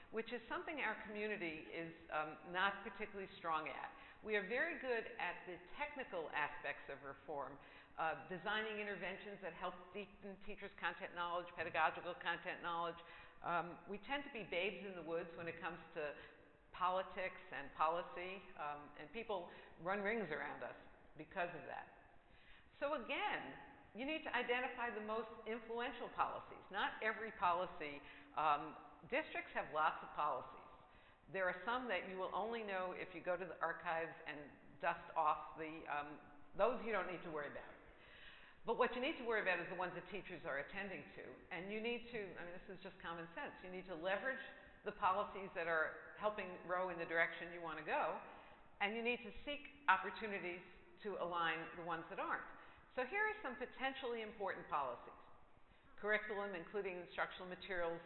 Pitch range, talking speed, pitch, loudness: 165-215 Hz, 175 wpm, 185 Hz, -44 LUFS